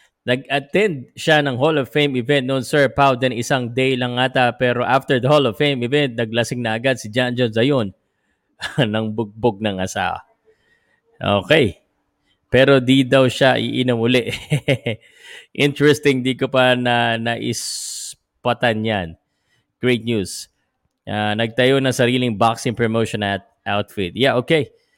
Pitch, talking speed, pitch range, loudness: 125 Hz, 140 wpm, 115-140 Hz, -18 LUFS